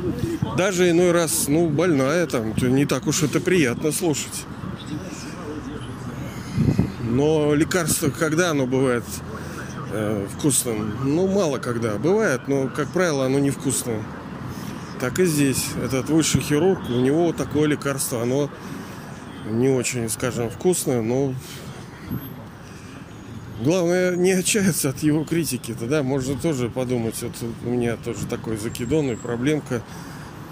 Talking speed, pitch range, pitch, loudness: 125 wpm, 120-160 Hz, 135 Hz, -22 LUFS